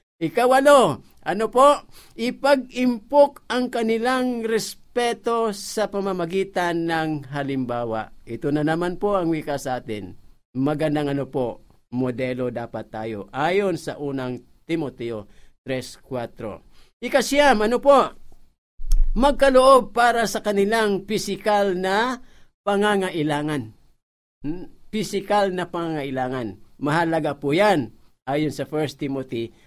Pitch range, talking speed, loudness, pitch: 135-225 Hz, 105 wpm, -22 LUFS, 175 Hz